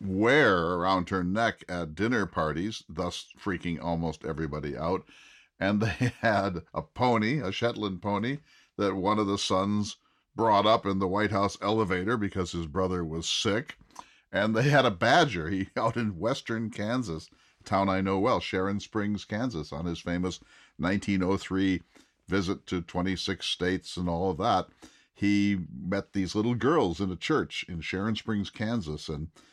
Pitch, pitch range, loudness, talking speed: 95 Hz, 90-105 Hz, -29 LUFS, 165 wpm